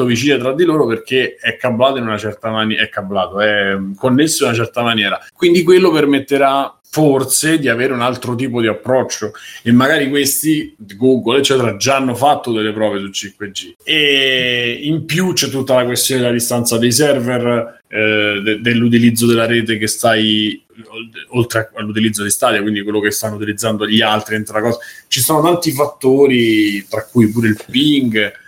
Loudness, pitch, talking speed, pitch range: -14 LUFS, 120 Hz, 170 wpm, 110-135 Hz